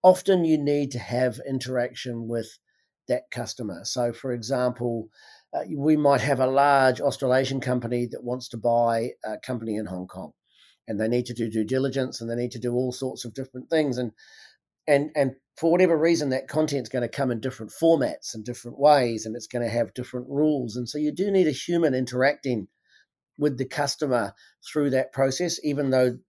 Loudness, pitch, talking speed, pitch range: -25 LUFS, 130 Hz, 200 wpm, 120-145 Hz